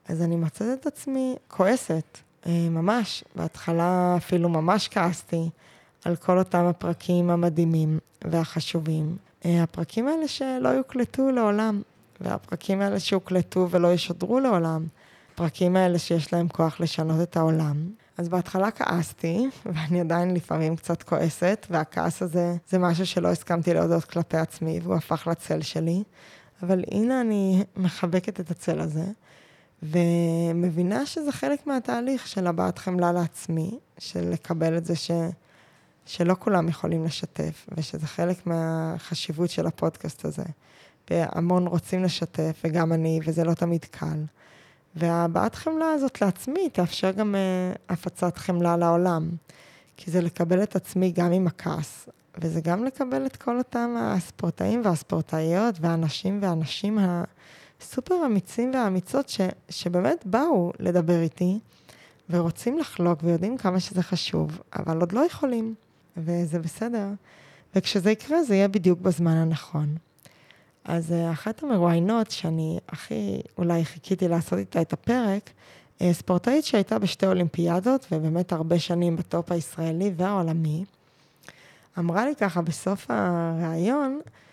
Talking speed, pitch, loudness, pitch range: 125 wpm, 175 Hz, -26 LUFS, 165-195 Hz